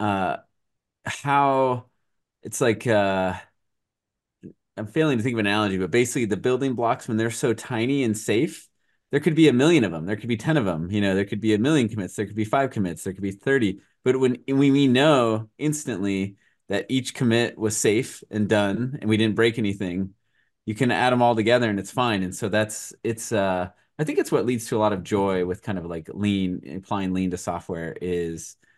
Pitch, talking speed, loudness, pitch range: 110 Hz, 220 wpm, -23 LUFS, 100-125 Hz